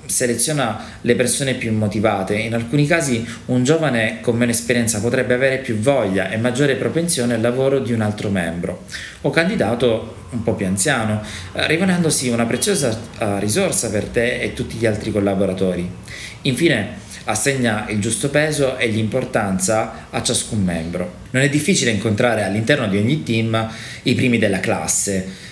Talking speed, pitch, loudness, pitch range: 155 wpm, 115 Hz, -18 LUFS, 105-130 Hz